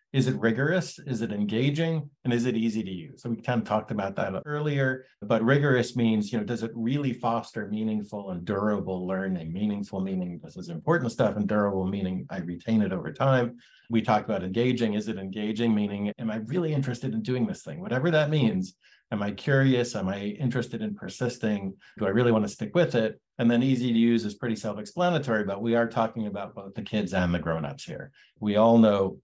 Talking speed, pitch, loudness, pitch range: 215 wpm, 115 Hz, -27 LUFS, 105-130 Hz